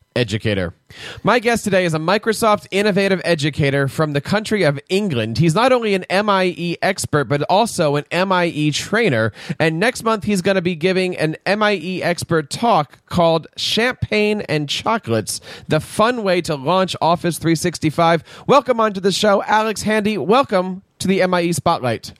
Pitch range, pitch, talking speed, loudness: 155-205 Hz, 180 Hz, 160 wpm, -18 LUFS